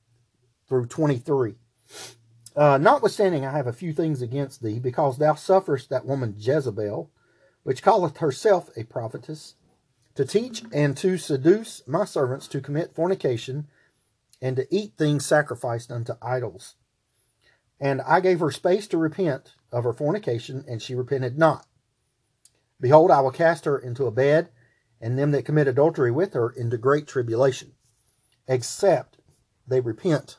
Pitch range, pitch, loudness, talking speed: 120-155 Hz, 135 Hz, -23 LUFS, 145 wpm